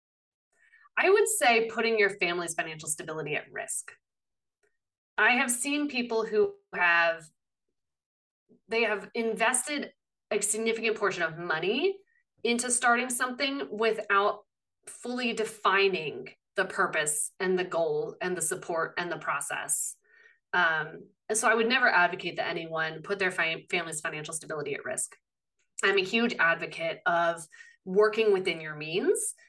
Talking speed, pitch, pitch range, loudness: 135 wpm, 215 Hz, 175-250 Hz, -28 LUFS